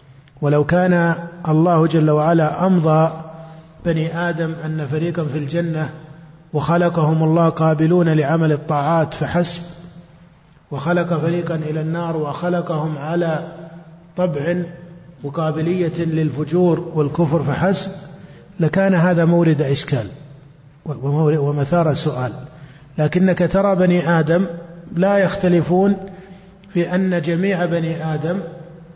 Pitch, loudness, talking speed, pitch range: 165 Hz, -18 LUFS, 95 wpm, 155-175 Hz